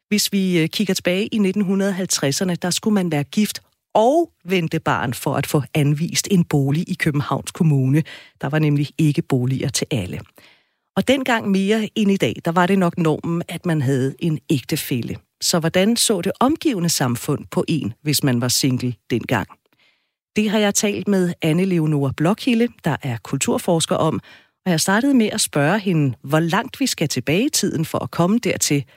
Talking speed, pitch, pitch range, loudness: 185 wpm, 170 Hz, 145-195 Hz, -19 LUFS